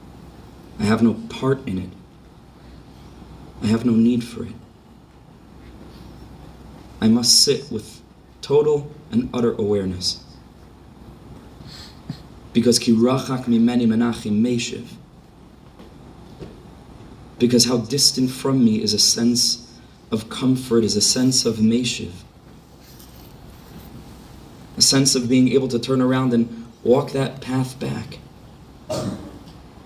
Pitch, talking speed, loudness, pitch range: 120 Hz, 110 wpm, -19 LUFS, 115-130 Hz